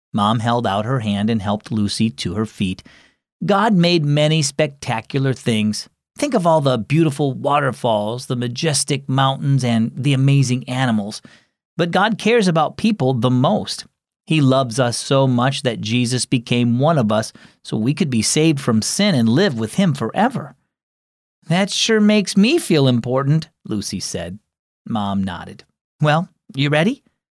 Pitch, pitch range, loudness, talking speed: 135 Hz, 115-160 Hz, -18 LUFS, 160 wpm